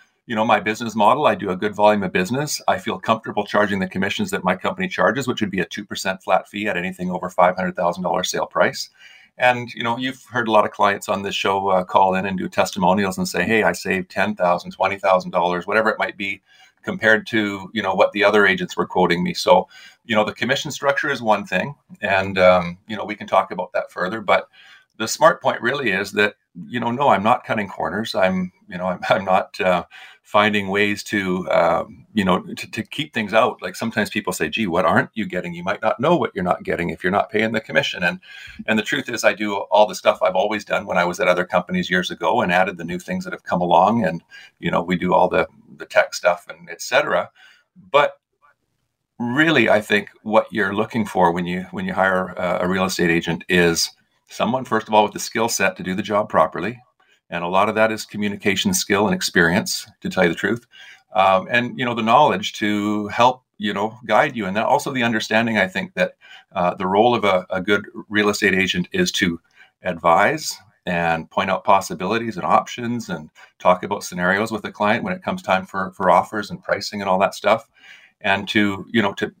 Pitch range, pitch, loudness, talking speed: 95-115 Hz, 105 Hz, -20 LUFS, 230 wpm